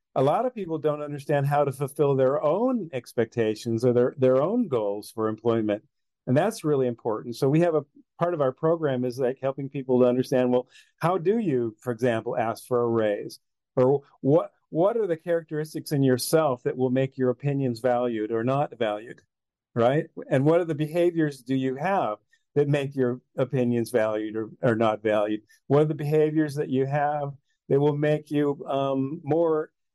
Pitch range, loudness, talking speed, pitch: 120-150 Hz, -25 LUFS, 190 wpm, 135 Hz